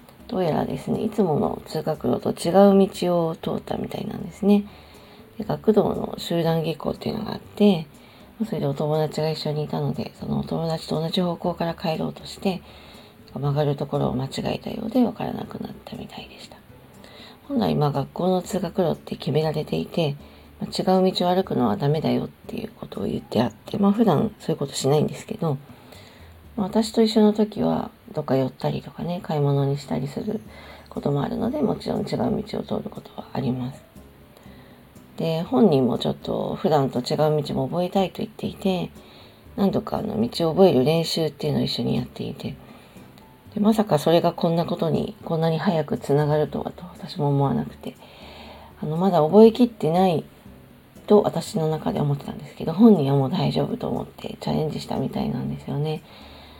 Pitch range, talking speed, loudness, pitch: 150-205 Hz, 375 characters per minute, -23 LUFS, 170 Hz